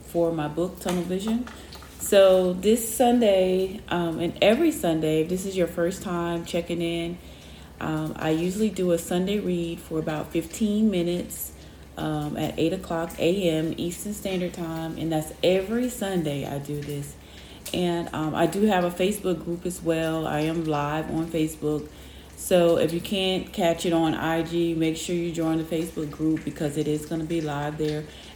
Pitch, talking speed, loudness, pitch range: 170 Hz, 180 wpm, -25 LUFS, 155-180 Hz